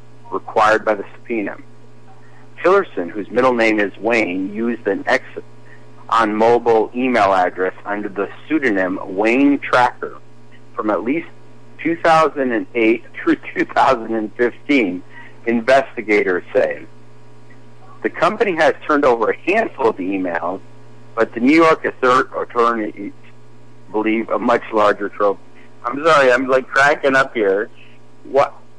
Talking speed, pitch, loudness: 120 wpm, 105 Hz, -17 LUFS